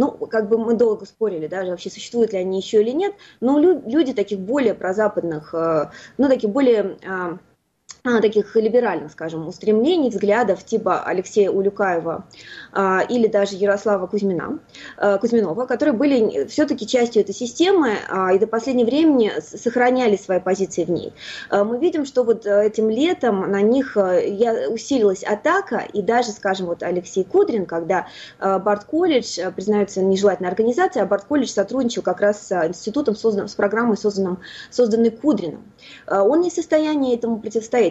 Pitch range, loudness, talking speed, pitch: 195-245 Hz, -20 LUFS, 140 wpm, 215 Hz